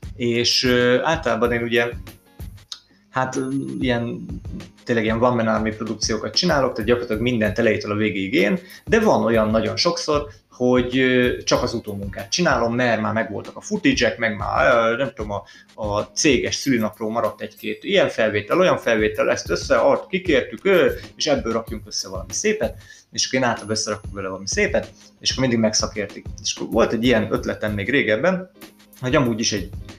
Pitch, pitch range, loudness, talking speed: 115 Hz, 105-125 Hz, -20 LUFS, 160 wpm